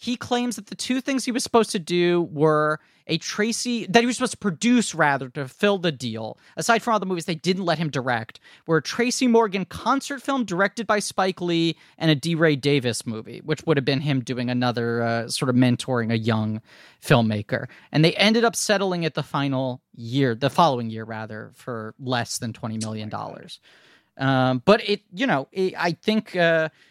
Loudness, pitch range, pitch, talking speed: -23 LUFS, 125-205 Hz, 160 Hz, 205 wpm